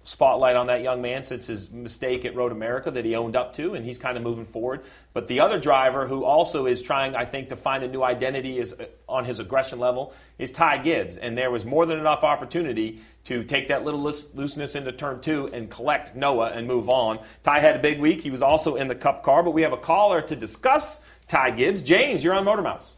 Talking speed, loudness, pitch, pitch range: 245 wpm, -23 LUFS, 130 Hz, 125-150 Hz